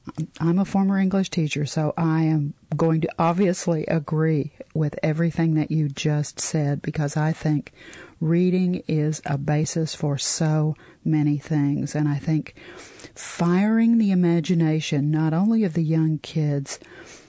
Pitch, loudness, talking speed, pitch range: 155 Hz, -23 LUFS, 140 wpm, 150-170 Hz